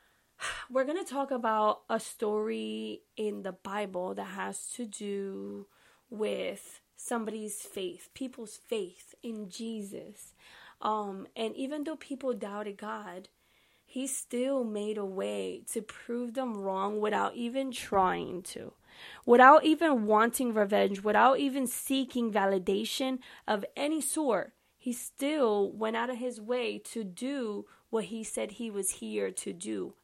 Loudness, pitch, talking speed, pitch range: -31 LUFS, 225 Hz, 140 wpm, 200-260 Hz